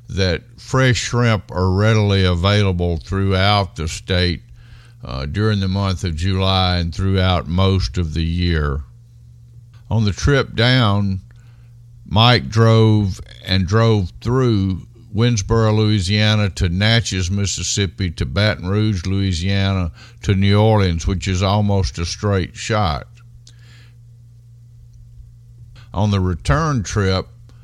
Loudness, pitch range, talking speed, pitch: -18 LUFS, 95-115 Hz, 115 wpm, 105 Hz